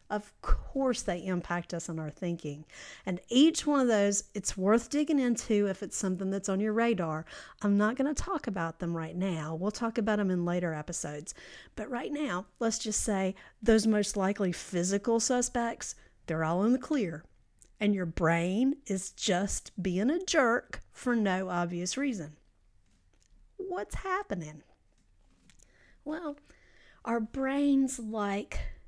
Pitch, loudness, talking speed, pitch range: 200 Hz, -31 LUFS, 155 wpm, 175-240 Hz